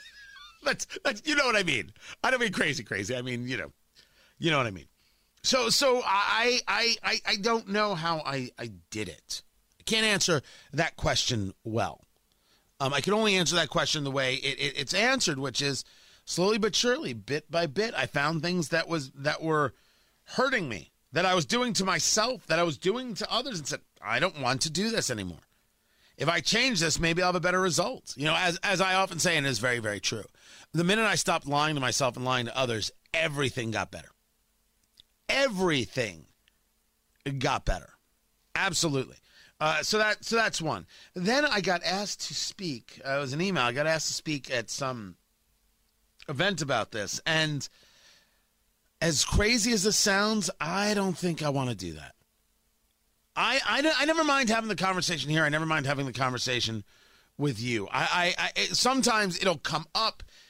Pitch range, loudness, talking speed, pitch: 135-195 Hz, -27 LUFS, 195 wpm, 165 Hz